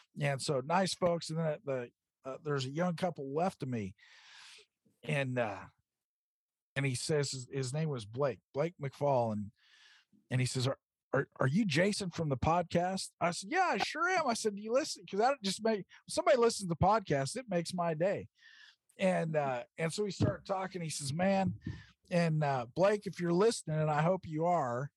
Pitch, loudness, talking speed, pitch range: 165 Hz, -34 LUFS, 200 wpm, 135-190 Hz